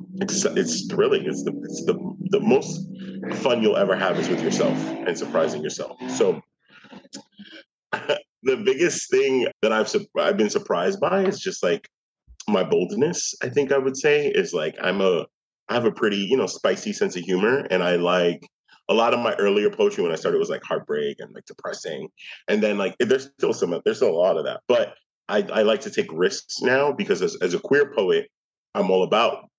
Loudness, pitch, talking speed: -23 LUFS, 210 Hz, 205 wpm